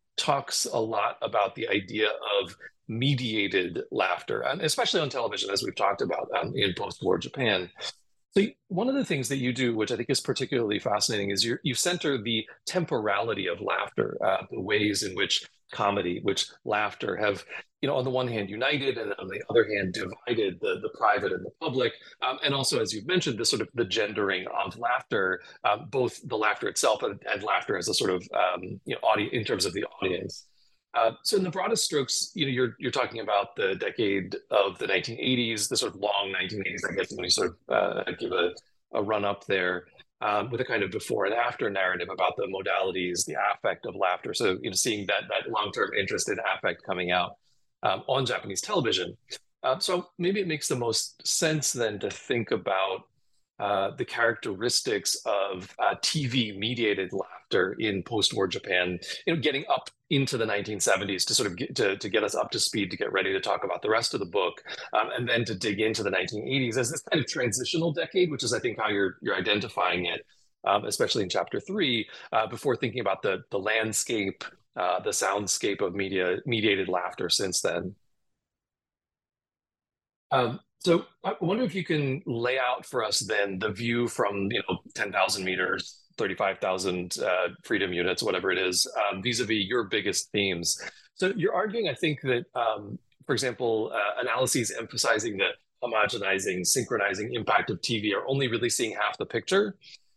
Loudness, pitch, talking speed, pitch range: -28 LUFS, 120 Hz, 195 wpm, 100-170 Hz